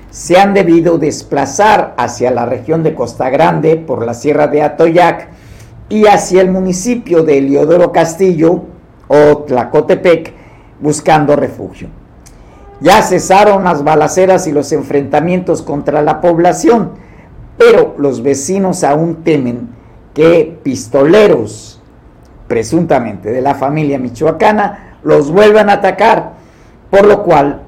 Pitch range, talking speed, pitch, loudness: 140-185 Hz, 120 wpm, 160 Hz, -10 LUFS